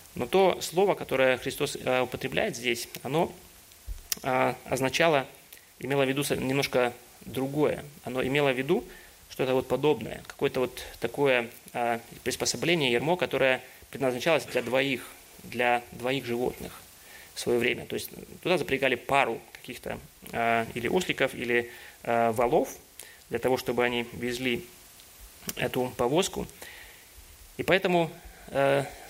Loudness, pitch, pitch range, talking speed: -28 LUFS, 130 Hz, 120-140 Hz, 125 wpm